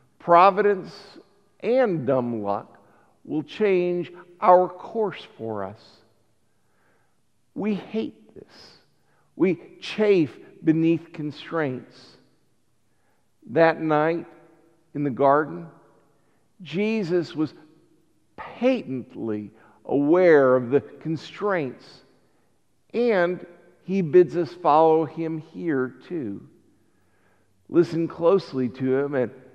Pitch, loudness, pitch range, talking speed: 160 Hz, -23 LUFS, 130-175 Hz, 85 wpm